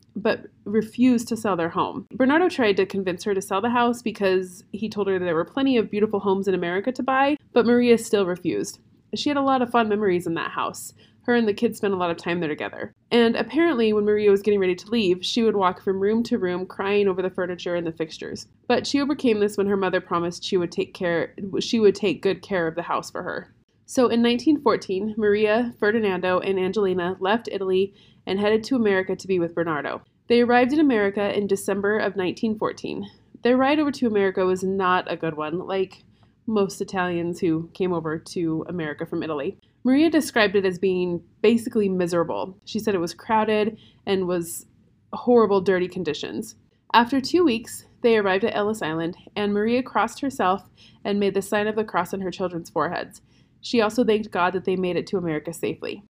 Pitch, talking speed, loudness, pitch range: 200 Hz, 210 wpm, -23 LUFS, 180-230 Hz